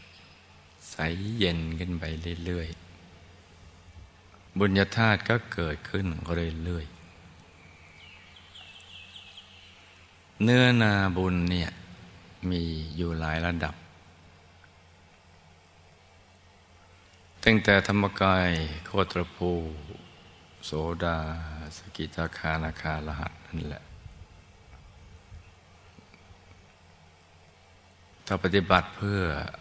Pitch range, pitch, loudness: 85-95 Hz, 90 Hz, -28 LUFS